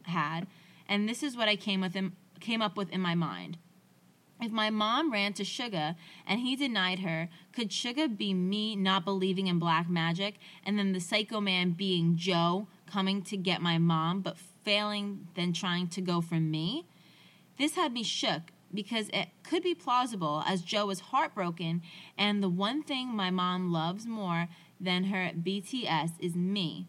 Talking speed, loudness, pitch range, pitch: 180 wpm, -31 LUFS, 175-210 Hz, 190 Hz